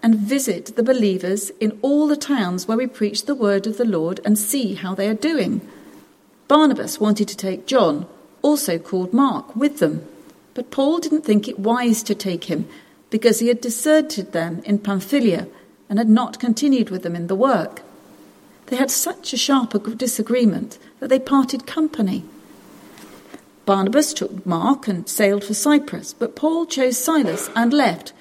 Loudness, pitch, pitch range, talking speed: -20 LUFS, 230 Hz, 200-270 Hz, 170 wpm